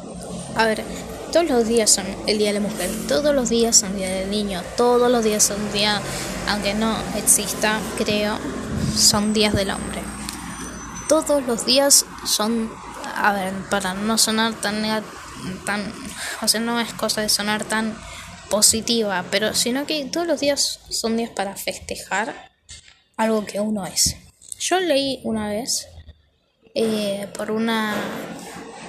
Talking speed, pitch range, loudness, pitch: 150 wpm, 200-230 Hz, -20 LUFS, 215 Hz